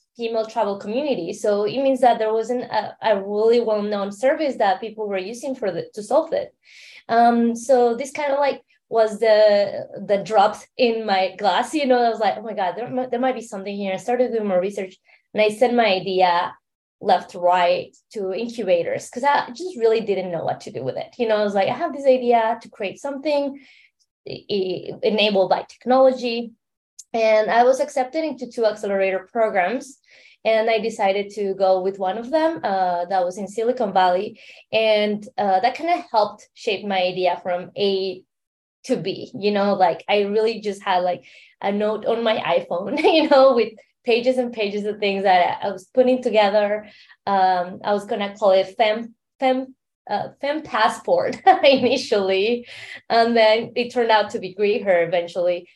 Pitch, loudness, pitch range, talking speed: 220 Hz, -20 LUFS, 195-245 Hz, 190 wpm